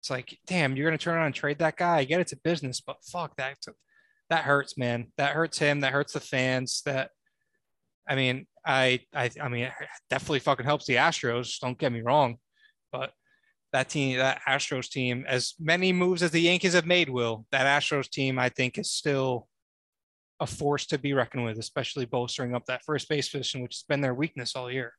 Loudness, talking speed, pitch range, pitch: -27 LUFS, 210 wpm, 125-160 Hz, 140 Hz